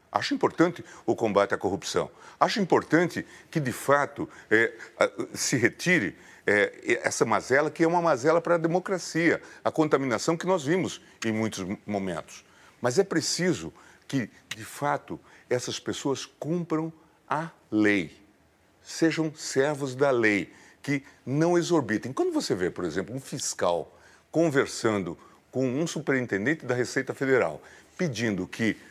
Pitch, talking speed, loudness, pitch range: 155 Hz, 135 wpm, -27 LUFS, 115-165 Hz